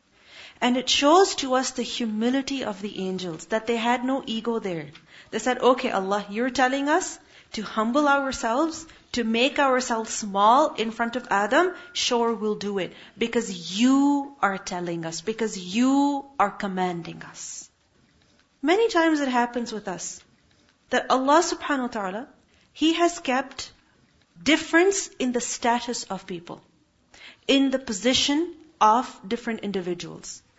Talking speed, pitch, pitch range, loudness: 145 wpm, 240 Hz, 210-280 Hz, -24 LUFS